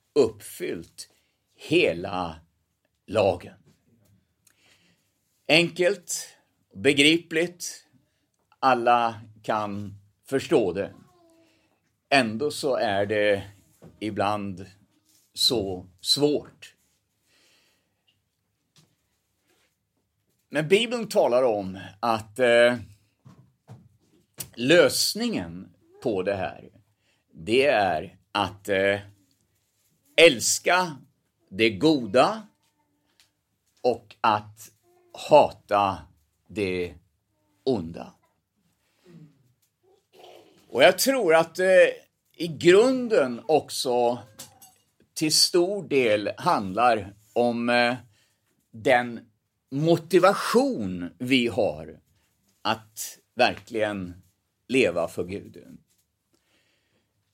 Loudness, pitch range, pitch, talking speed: -23 LUFS, 100-150 Hz, 110 Hz, 65 wpm